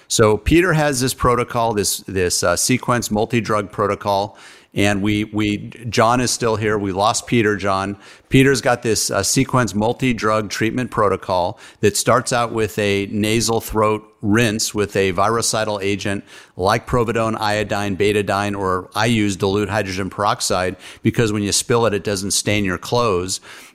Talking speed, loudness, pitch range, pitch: 160 wpm, -18 LUFS, 100-115 Hz, 105 Hz